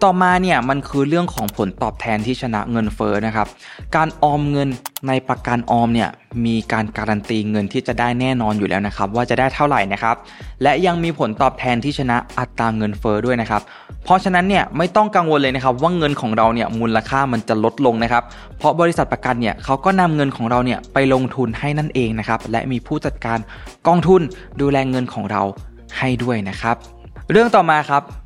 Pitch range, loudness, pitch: 110-140 Hz, -18 LUFS, 125 Hz